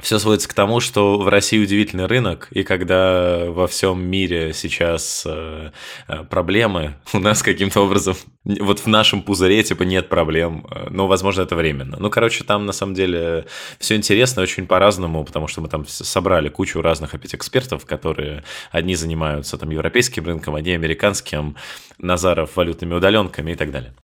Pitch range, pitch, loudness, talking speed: 80-100 Hz, 90 Hz, -18 LUFS, 160 wpm